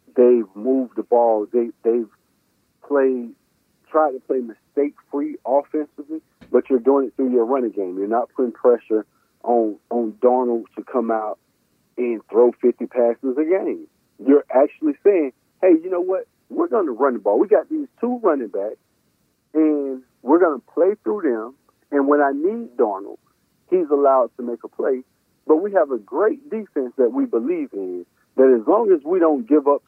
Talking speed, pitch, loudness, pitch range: 185 wpm, 140 Hz, -20 LUFS, 120-185 Hz